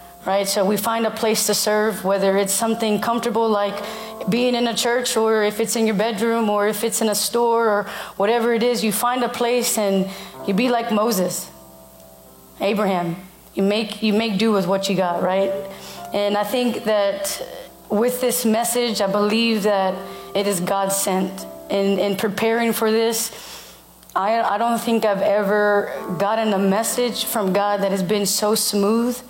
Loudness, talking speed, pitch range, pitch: -20 LUFS, 180 wpm, 195-230 Hz, 210 Hz